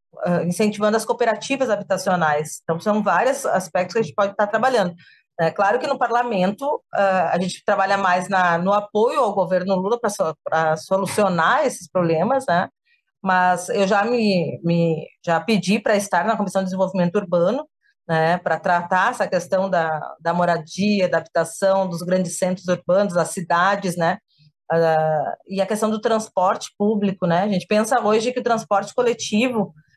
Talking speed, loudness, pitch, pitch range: 160 wpm, -20 LUFS, 190 Hz, 175-210 Hz